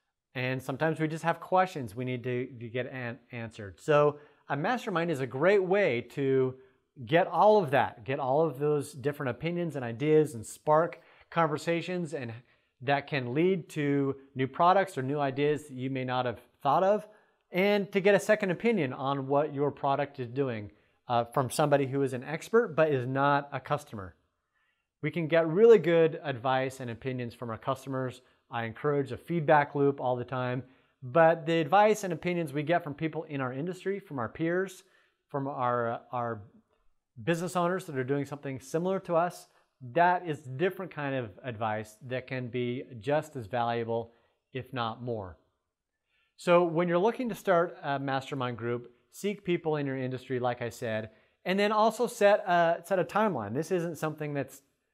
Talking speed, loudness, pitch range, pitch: 180 wpm, -29 LUFS, 125-170 Hz, 140 Hz